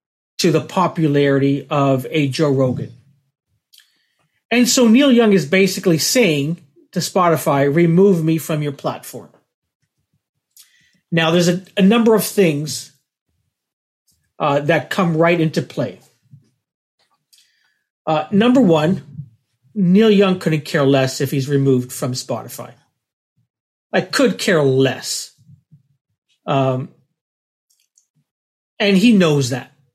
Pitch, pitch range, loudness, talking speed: 155 Hz, 140-185 Hz, -16 LUFS, 110 wpm